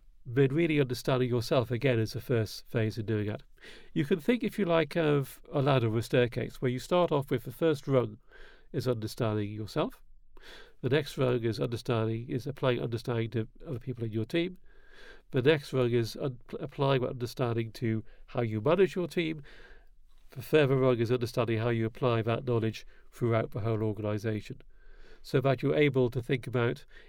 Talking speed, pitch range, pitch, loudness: 185 wpm, 115-145 Hz, 125 Hz, -30 LUFS